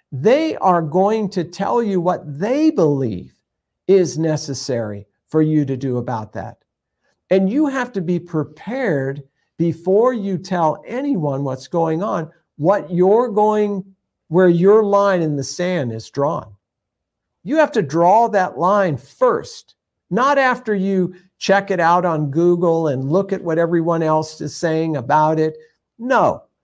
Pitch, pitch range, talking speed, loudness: 175 Hz, 150-200 Hz, 150 wpm, -18 LUFS